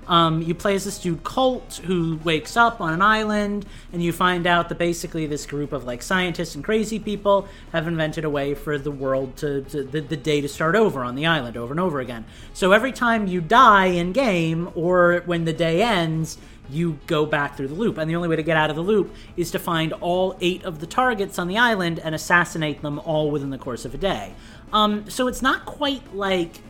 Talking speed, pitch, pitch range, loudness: 235 wpm, 170 Hz, 150-195 Hz, -22 LUFS